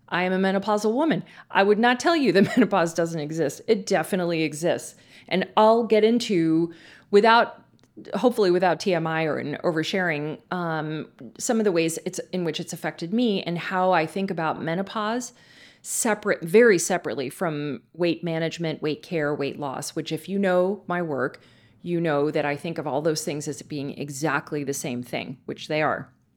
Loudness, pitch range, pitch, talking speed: -24 LUFS, 155-195 Hz, 170 Hz, 180 wpm